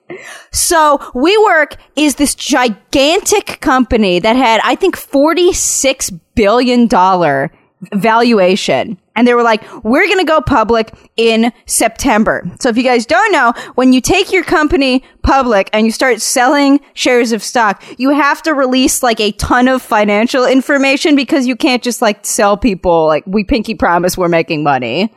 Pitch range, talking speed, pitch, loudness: 215-285 Hz, 160 wpm, 250 Hz, -11 LUFS